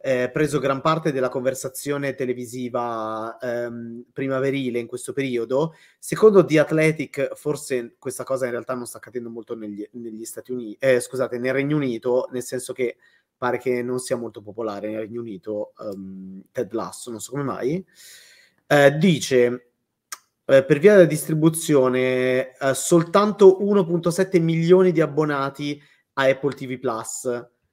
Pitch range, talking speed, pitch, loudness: 120-150 Hz, 150 wpm, 130 Hz, -21 LUFS